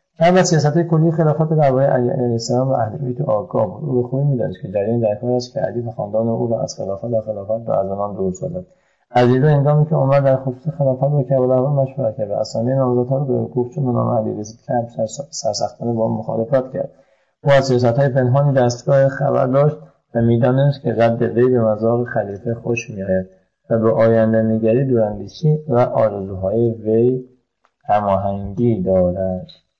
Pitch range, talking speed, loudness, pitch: 110-135 Hz, 155 wpm, -18 LUFS, 125 Hz